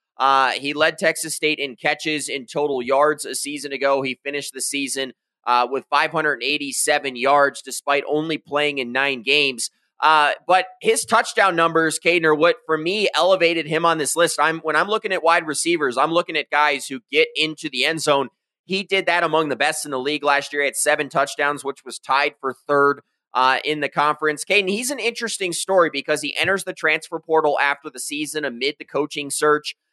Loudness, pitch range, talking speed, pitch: -20 LUFS, 140-165 Hz, 205 wpm, 150 Hz